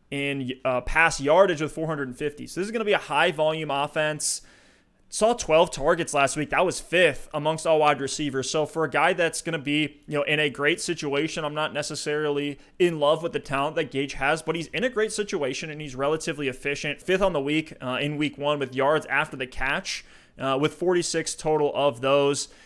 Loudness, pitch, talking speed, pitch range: -25 LUFS, 150 Hz, 215 wpm, 140-165 Hz